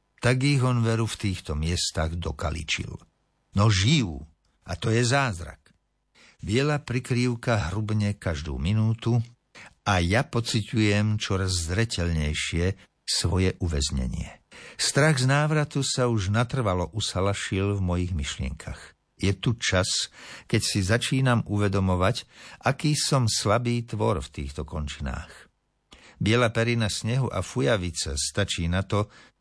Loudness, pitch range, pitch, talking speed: -25 LUFS, 90-120 Hz, 105 Hz, 120 wpm